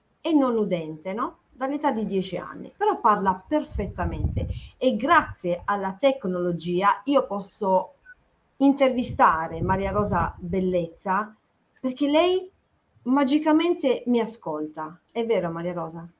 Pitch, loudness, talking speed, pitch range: 210 Hz, -24 LUFS, 110 wpm, 180-275 Hz